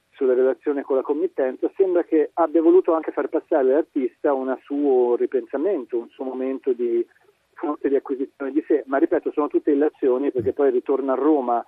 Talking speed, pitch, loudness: 180 wpm, 165 Hz, -22 LUFS